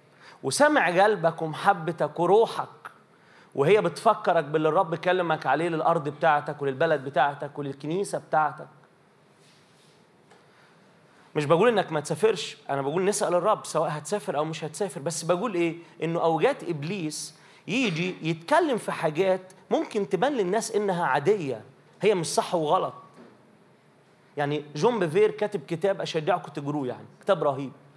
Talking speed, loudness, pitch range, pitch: 125 wpm, -26 LUFS, 155-200 Hz, 170 Hz